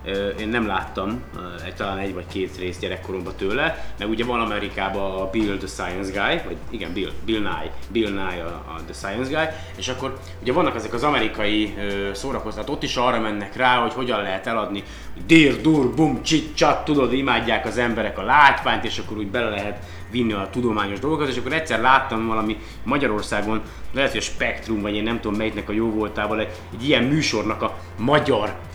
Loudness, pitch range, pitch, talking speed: -22 LUFS, 100-120 Hz, 110 Hz, 190 wpm